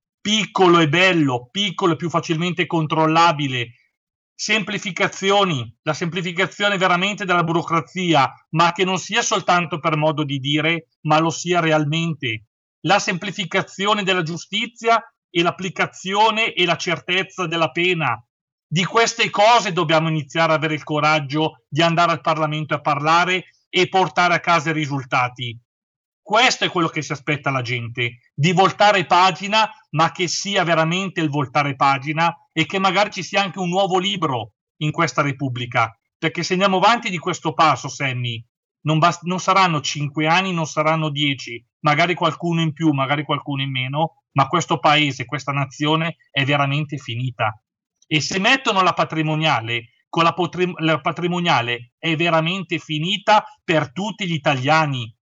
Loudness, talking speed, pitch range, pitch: -19 LUFS, 150 wpm, 150-185 Hz, 165 Hz